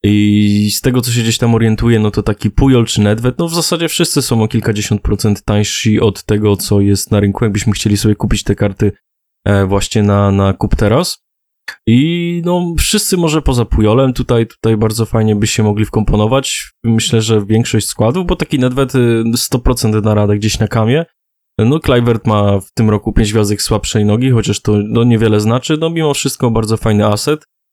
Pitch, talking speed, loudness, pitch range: 110 Hz, 190 wpm, -13 LUFS, 105-125 Hz